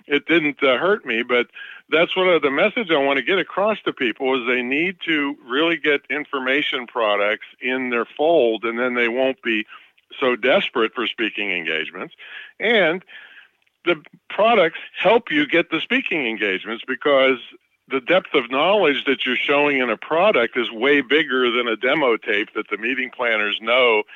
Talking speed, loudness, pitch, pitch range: 175 wpm, -19 LUFS, 140 Hz, 125-165 Hz